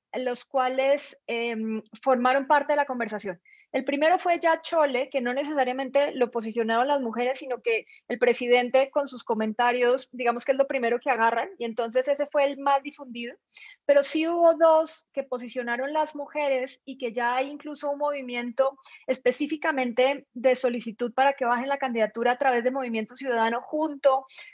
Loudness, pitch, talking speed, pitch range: -26 LUFS, 260 Hz, 170 wpm, 245-285 Hz